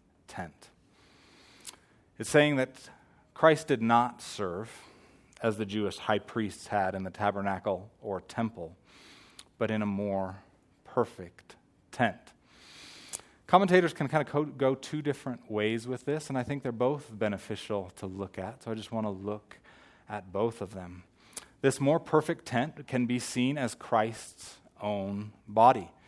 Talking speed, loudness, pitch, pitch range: 150 wpm, -30 LUFS, 115 Hz, 100-135 Hz